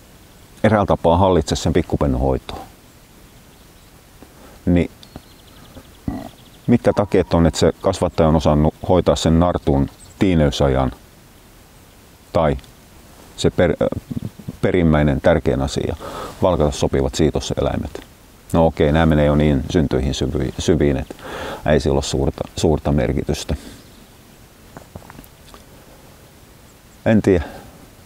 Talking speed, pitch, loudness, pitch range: 100 wpm, 80 Hz, -18 LUFS, 70-90 Hz